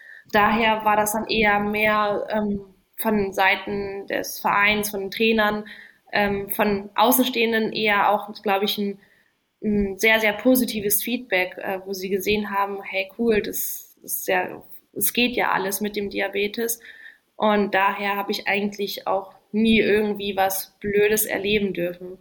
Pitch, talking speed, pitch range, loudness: 205 Hz, 150 wpm, 200-215 Hz, -22 LUFS